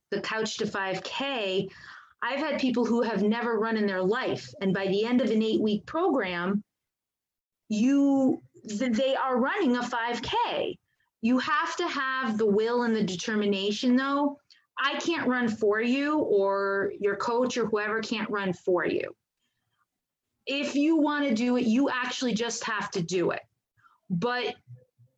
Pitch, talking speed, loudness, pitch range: 235 Hz, 160 wpm, -27 LUFS, 205-265 Hz